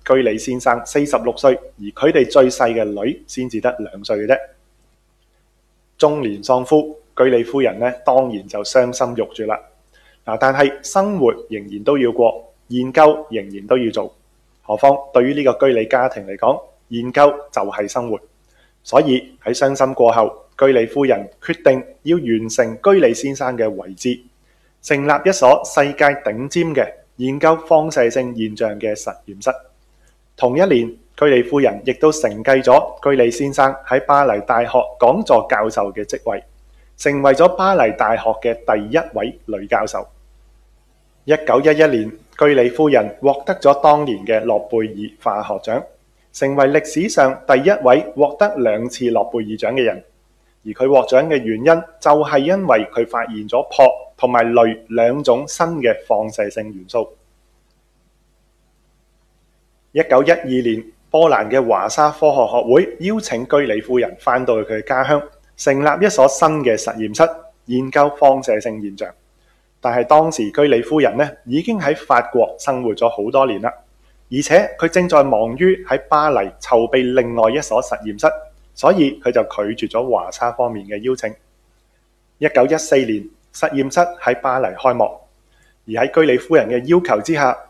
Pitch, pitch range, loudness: 130 Hz, 115-145 Hz, -16 LUFS